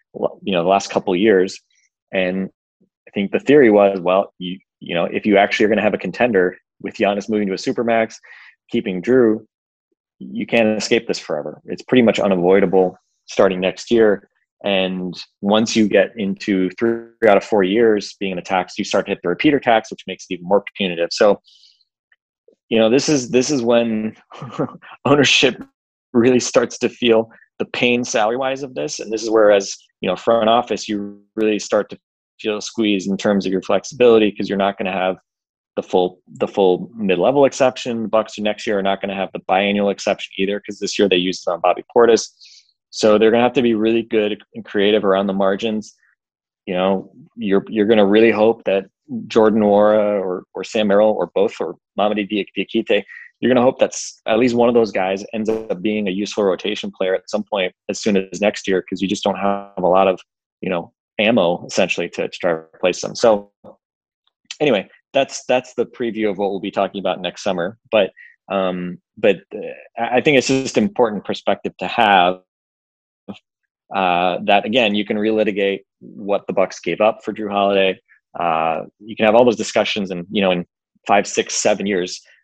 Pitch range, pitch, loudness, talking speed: 95-110 Hz, 105 Hz, -18 LUFS, 200 wpm